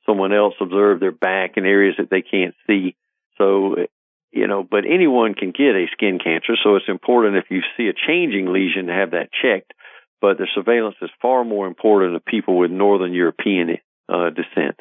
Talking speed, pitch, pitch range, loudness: 195 wpm, 100 Hz, 95-105 Hz, -18 LUFS